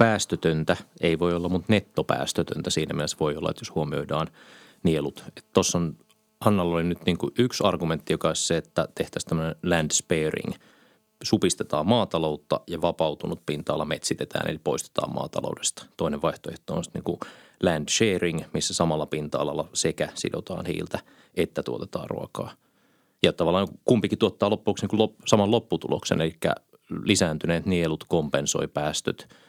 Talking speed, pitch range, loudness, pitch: 140 wpm, 80-105 Hz, -26 LUFS, 85 Hz